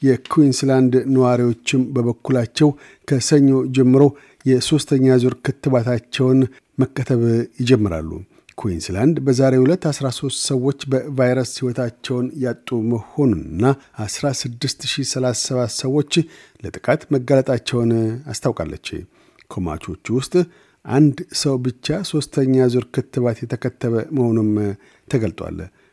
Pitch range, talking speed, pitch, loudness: 120-140 Hz, 80 wpm, 130 Hz, -19 LUFS